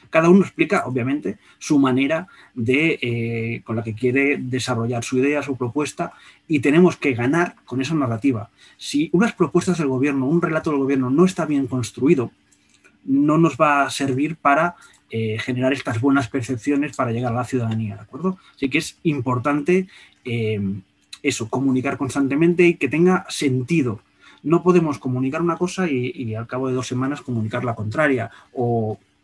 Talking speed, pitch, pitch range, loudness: 170 wpm, 135 Hz, 125-155 Hz, -21 LUFS